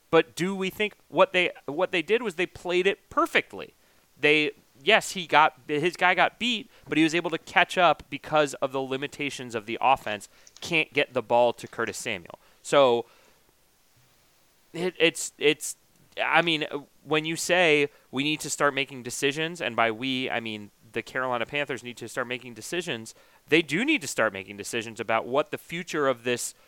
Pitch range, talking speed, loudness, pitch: 125-170 Hz, 190 wpm, -26 LUFS, 145 Hz